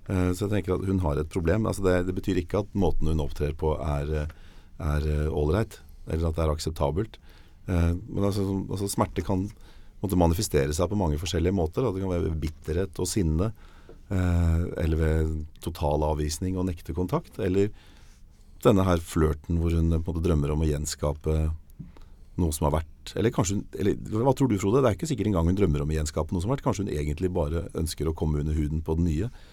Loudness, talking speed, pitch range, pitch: -27 LUFS, 205 wpm, 80-95 Hz, 85 Hz